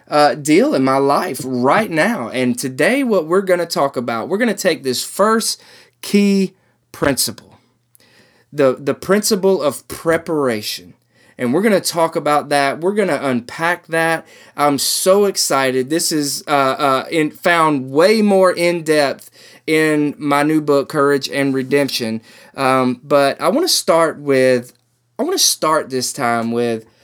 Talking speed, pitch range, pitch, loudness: 165 wpm, 130-175 Hz, 145 Hz, -16 LUFS